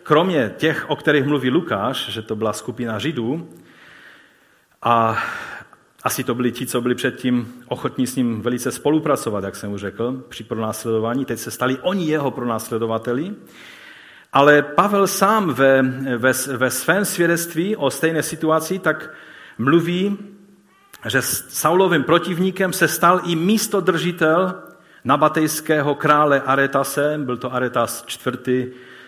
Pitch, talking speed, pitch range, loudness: 135 Hz, 130 wpm, 125-160 Hz, -19 LUFS